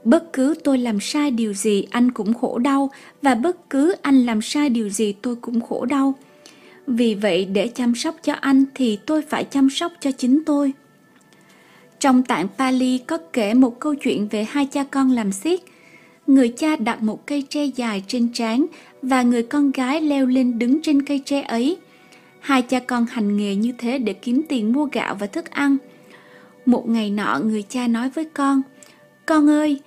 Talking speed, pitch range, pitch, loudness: 195 wpm, 235-285 Hz, 260 Hz, -20 LUFS